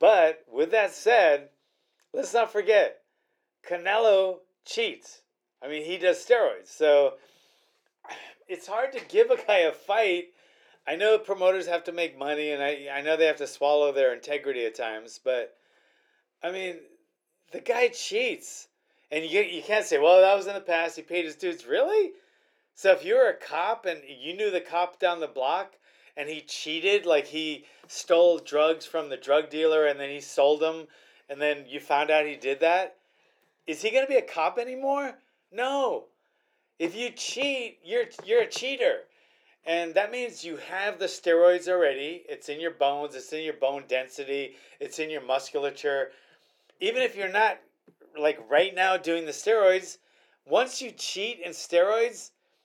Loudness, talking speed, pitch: -26 LUFS, 175 wpm, 185 Hz